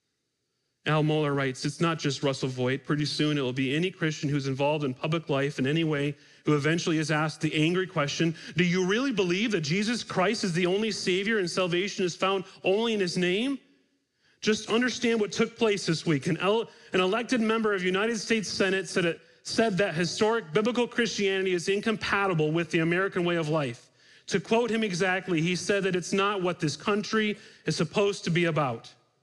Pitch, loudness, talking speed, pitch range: 180 Hz, -27 LUFS, 200 wpm, 155-205 Hz